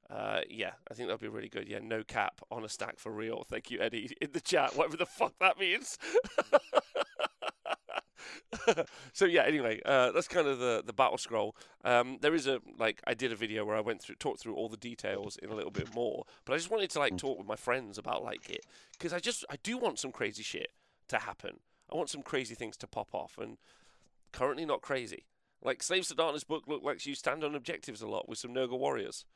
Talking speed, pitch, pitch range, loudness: 235 wpm, 145 Hz, 120-185 Hz, -34 LUFS